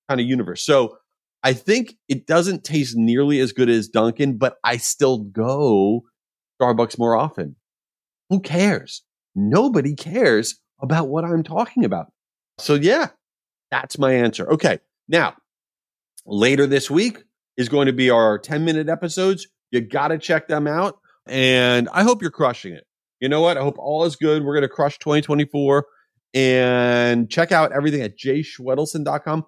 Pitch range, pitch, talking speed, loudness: 125-165 Hz, 145 Hz, 160 wpm, -19 LUFS